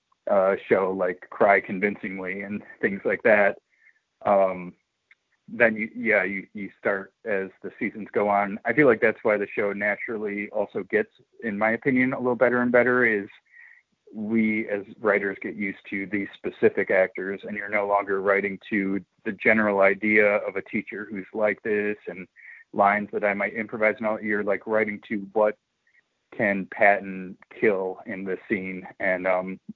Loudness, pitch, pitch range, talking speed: -24 LUFS, 100 Hz, 95-110 Hz, 175 wpm